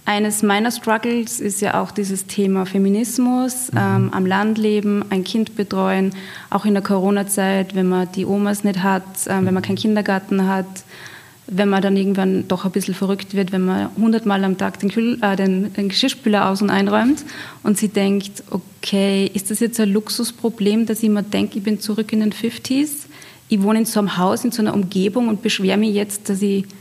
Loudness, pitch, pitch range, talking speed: -19 LUFS, 205 Hz, 195-220 Hz, 205 wpm